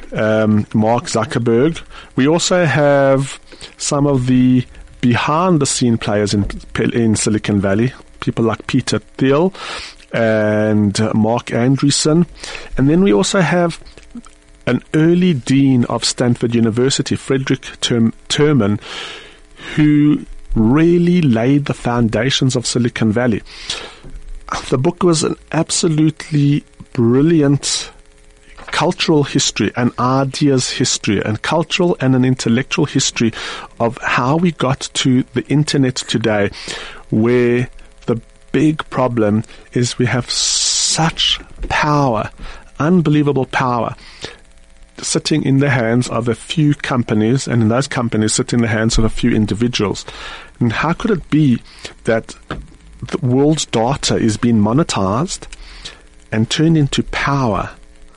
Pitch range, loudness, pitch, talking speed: 110-145 Hz, -15 LUFS, 125 Hz, 120 wpm